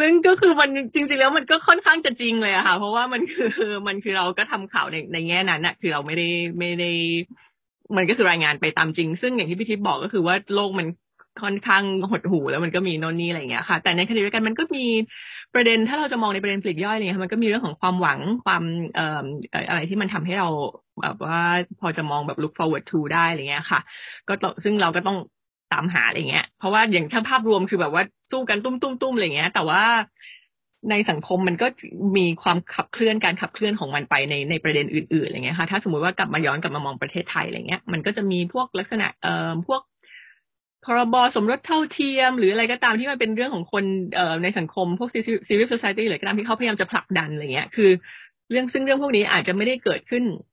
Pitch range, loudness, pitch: 175-230 Hz, -22 LUFS, 195 Hz